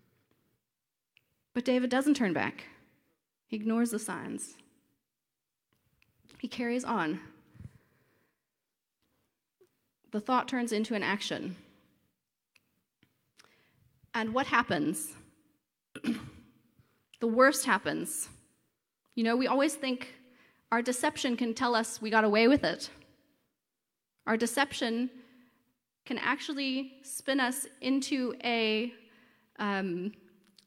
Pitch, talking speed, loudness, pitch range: 245 Hz, 95 wpm, -31 LUFS, 225-260 Hz